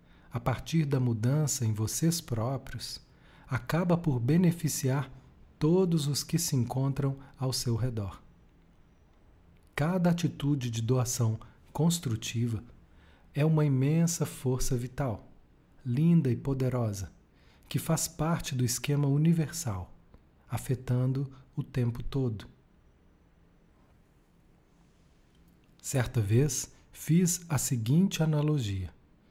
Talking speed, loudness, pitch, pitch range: 95 wpm, -30 LUFS, 130 Hz, 115-150 Hz